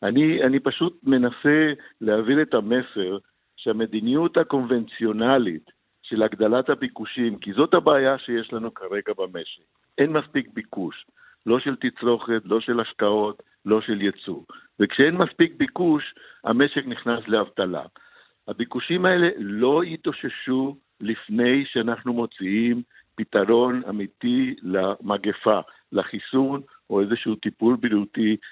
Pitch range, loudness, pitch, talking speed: 110-140 Hz, -23 LUFS, 120 Hz, 110 wpm